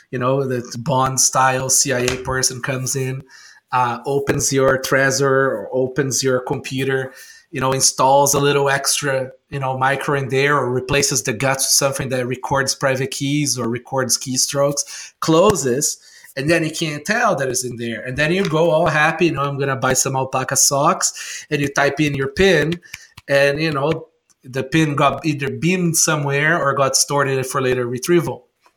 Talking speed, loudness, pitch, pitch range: 185 wpm, -17 LUFS, 135 Hz, 130-145 Hz